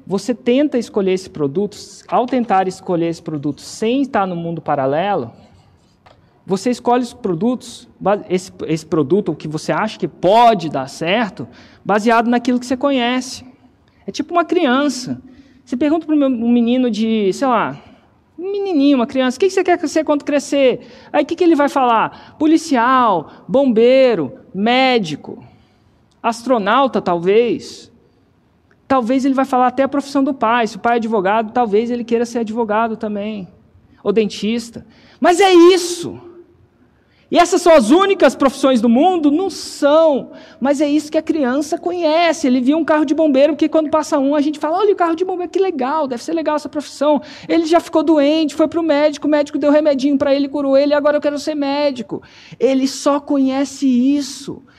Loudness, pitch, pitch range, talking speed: -16 LUFS, 270 Hz, 230-300 Hz, 175 wpm